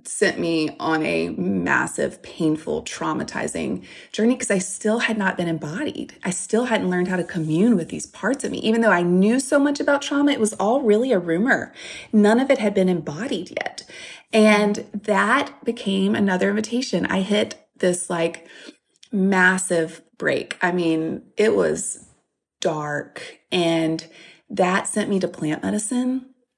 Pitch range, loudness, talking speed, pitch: 175-225 Hz, -21 LUFS, 160 wpm, 195 Hz